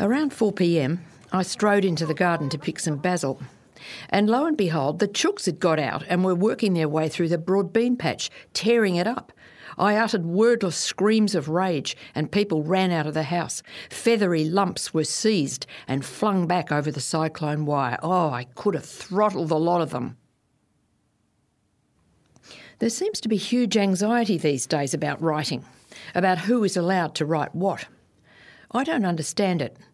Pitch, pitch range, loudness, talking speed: 180 Hz, 155-205 Hz, -24 LUFS, 175 wpm